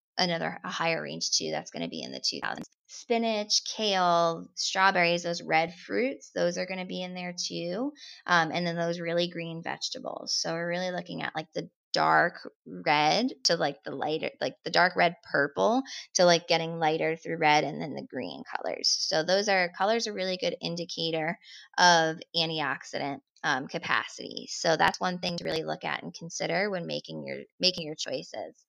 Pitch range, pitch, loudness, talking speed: 165-190 Hz, 175 Hz, -28 LUFS, 190 wpm